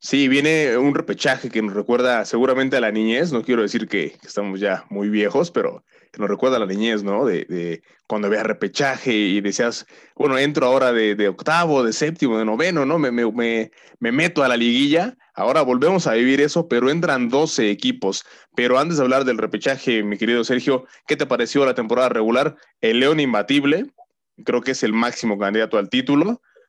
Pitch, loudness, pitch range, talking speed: 125 Hz, -19 LUFS, 110-145 Hz, 195 wpm